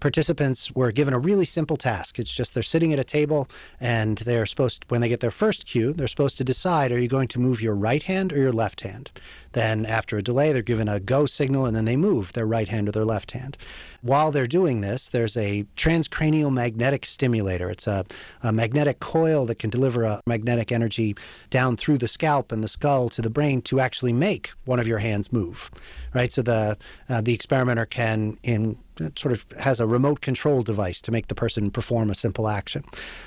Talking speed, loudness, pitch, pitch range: 220 wpm, -24 LUFS, 120 Hz, 110-140 Hz